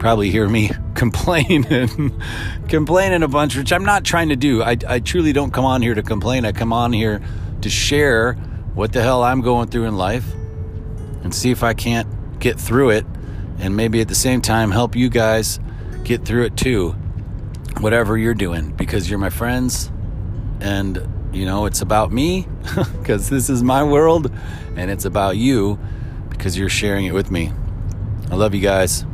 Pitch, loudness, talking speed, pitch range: 110 Hz, -18 LUFS, 185 wpm, 100-120 Hz